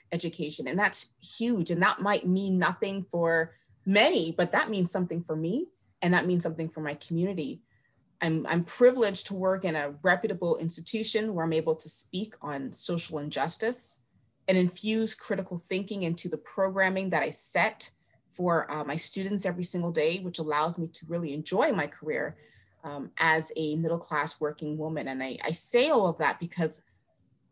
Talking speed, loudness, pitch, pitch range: 175 wpm, -29 LUFS, 170 Hz, 160-190 Hz